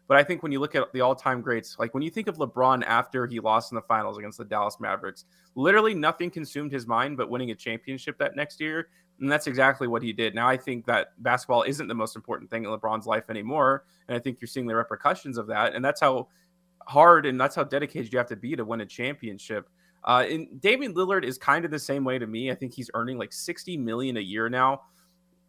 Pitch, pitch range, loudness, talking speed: 130 Hz, 115-155 Hz, -26 LUFS, 245 wpm